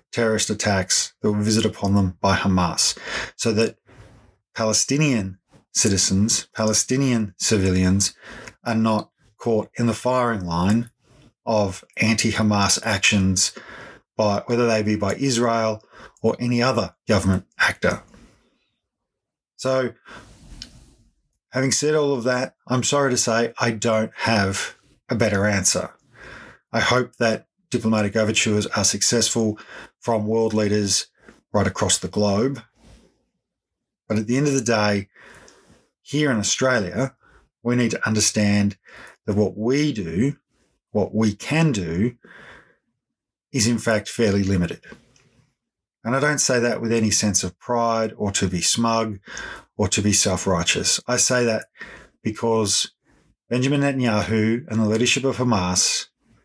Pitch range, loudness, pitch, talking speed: 105-120 Hz, -21 LUFS, 110 Hz, 130 wpm